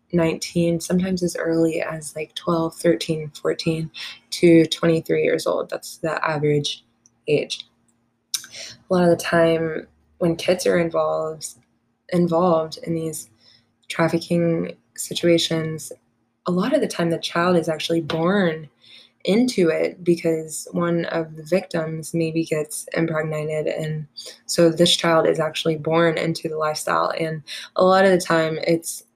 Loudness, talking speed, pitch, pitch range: -21 LUFS, 140 wpm, 165 Hz, 155-170 Hz